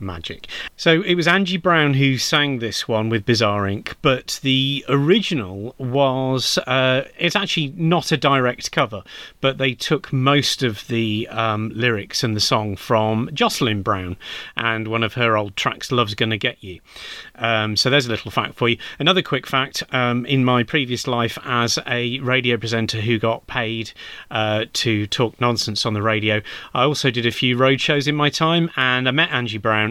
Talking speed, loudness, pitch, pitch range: 185 wpm, -19 LUFS, 125 Hz, 110-140 Hz